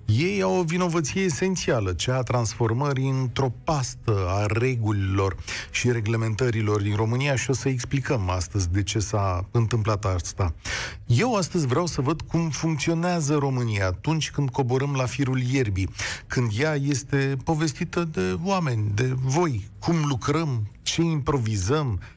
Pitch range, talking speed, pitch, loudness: 110-150 Hz, 140 wpm, 130 Hz, -25 LUFS